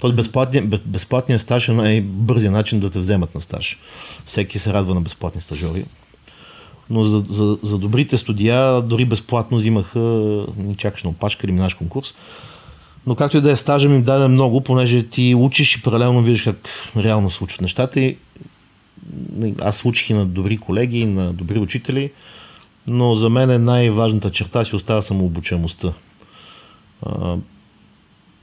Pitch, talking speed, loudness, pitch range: 110 Hz, 155 wpm, -18 LUFS, 100-125 Hz